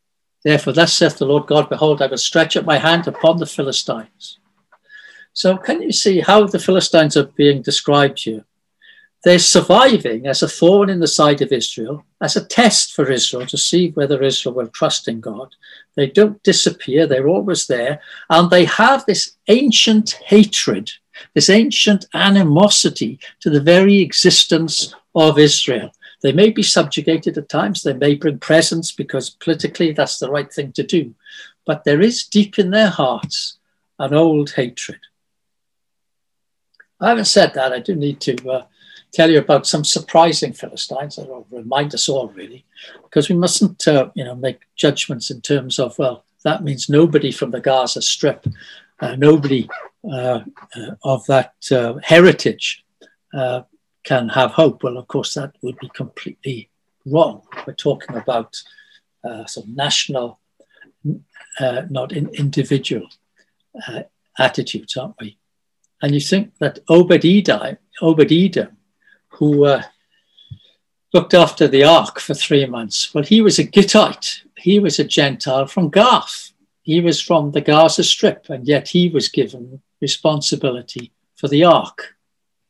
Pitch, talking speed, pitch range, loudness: 155 Hz, 155 wpm, 140-185 Hz, -15 LUFS